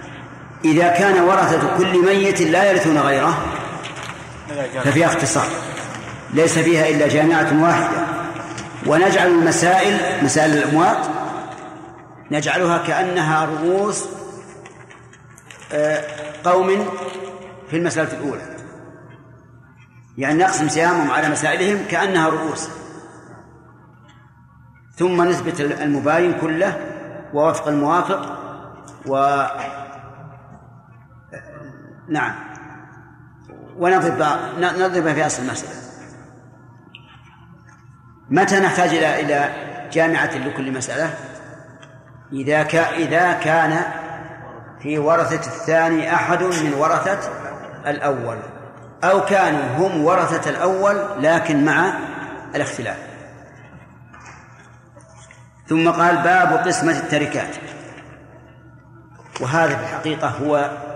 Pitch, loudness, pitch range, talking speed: 160 Hz, -18 LUFS, 145-175 Hz, 80 wpm